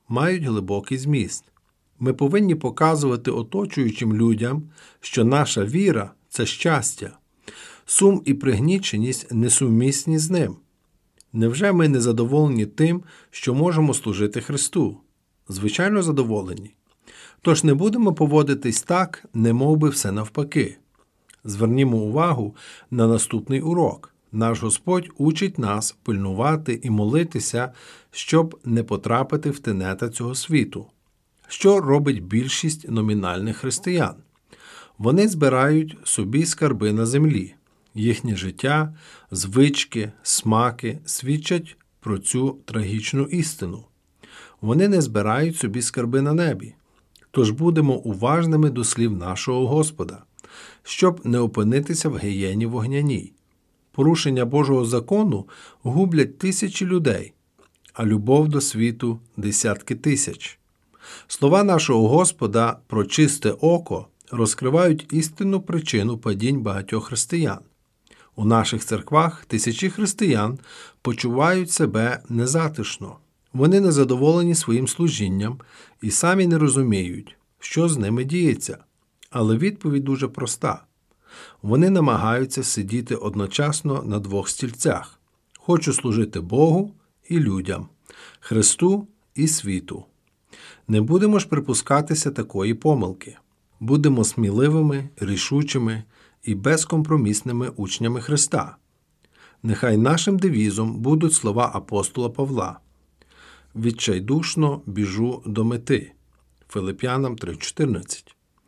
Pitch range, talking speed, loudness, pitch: 110-155 Hz, 105 wpm, -21 LUFS, 130 Hz